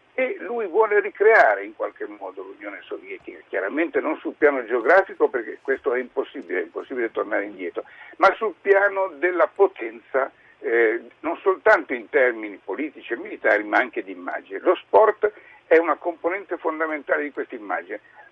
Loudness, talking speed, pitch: -22 LUFS, 155 wpm, 380 Hz